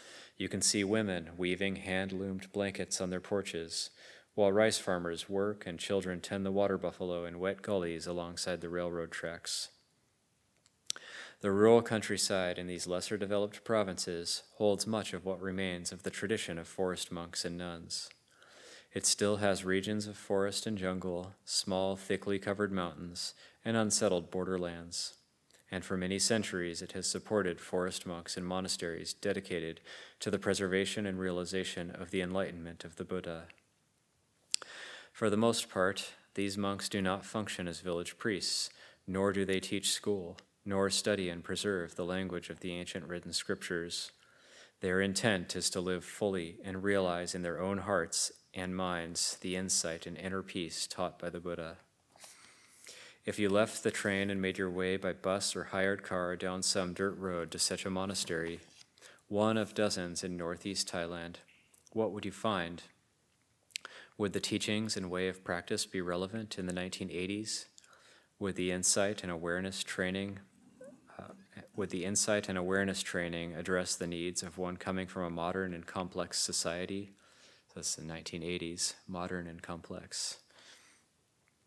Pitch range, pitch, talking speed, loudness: 90-100 Hz, 95 Hz, 155 wpm, -35 LUFS